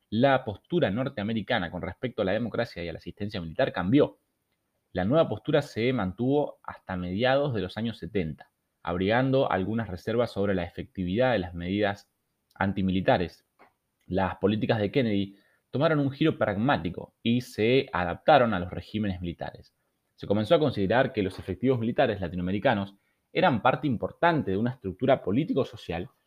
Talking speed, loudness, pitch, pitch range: 150 wpm, -27 LUFS, 105 Hz, 95-130 Hz